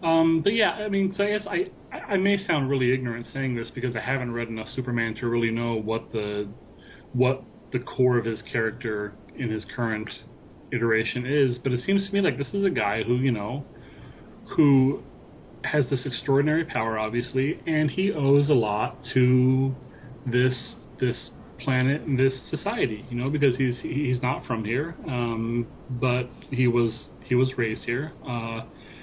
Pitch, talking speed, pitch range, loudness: 125 Hz, 180 wpm, 120-145 Hz, -26 LUFS